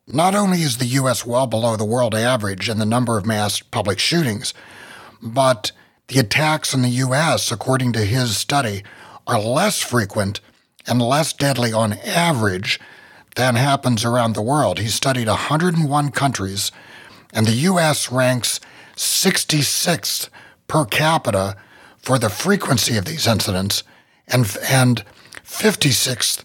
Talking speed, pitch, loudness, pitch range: 135 wpm, 125 Hz, -18 LUFS, 110-140 Hz